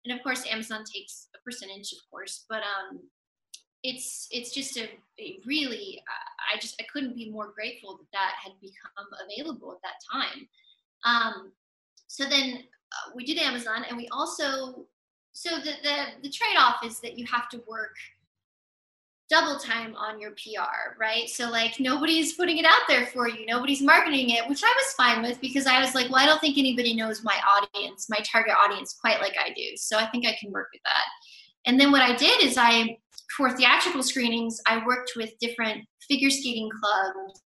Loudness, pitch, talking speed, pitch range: -24 LUFS, 245 Hz, 195 wpm, 225-285 Hz